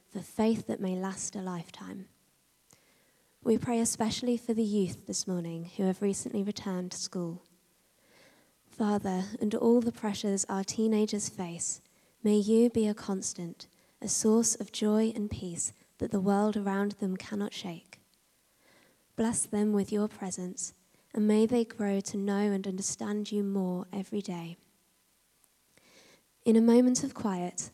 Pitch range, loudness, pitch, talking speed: 190-220 Hz, -31 LUFS, 205 Hz, 150 wpm